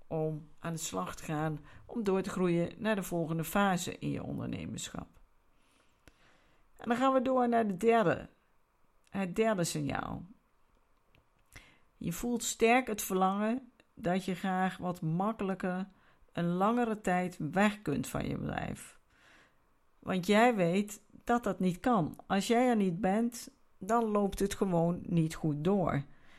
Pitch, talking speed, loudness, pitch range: 195 Hz, 150 wpm, -32 LUFS, 170-225 Hz